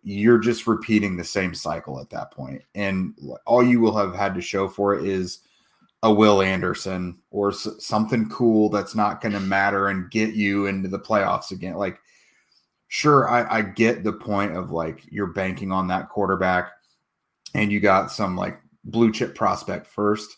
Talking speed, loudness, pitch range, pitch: 185 wpm, -22 LUFS, 95-110 Hz, 100 Hz